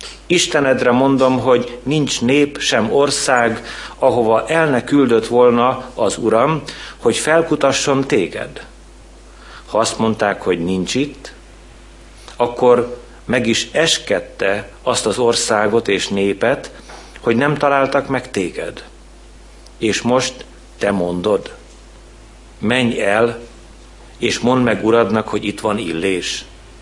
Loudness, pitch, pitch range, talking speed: -16 LUFS, 120 Hz, 110-135 Hz, 110 wpm